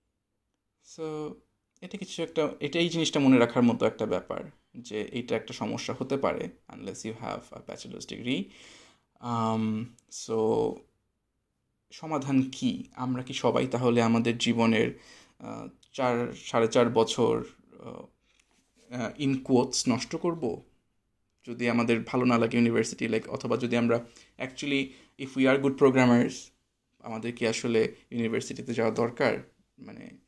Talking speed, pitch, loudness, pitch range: 125 wpm, 120 Hz, -28 LUFS, 115-135 Hz